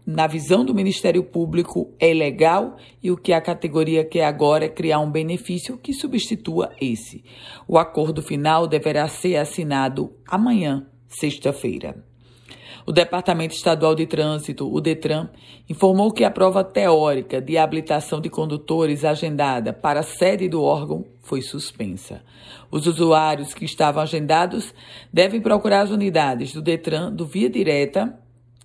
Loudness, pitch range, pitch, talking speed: -20 LUFS, 150-180 Hz, 160 Hz, 140 wpm